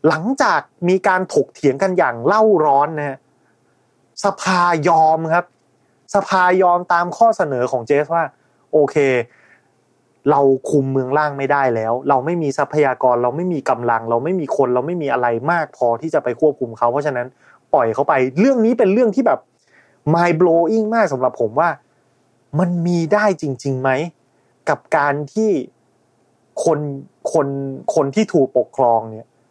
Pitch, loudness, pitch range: 145 Hz, -17 LUFS, 130-175 Hz